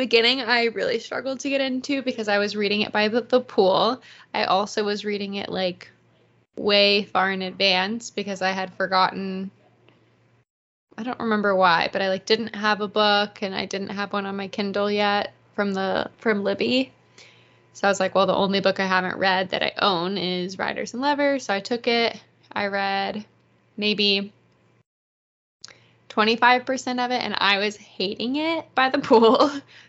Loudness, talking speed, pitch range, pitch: -22 LUFS, 180 wpm, 195-235 Hz, 205 Hz